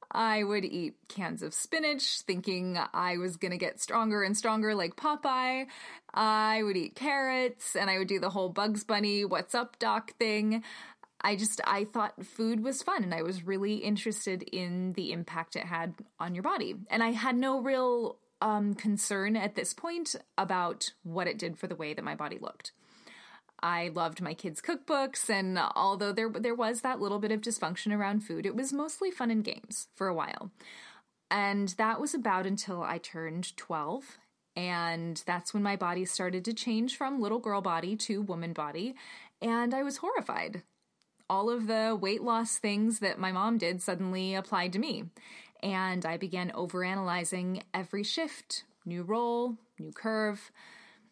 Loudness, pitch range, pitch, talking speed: -32 LUFS, 185-230 Hz, 205 Hz, 175 wpm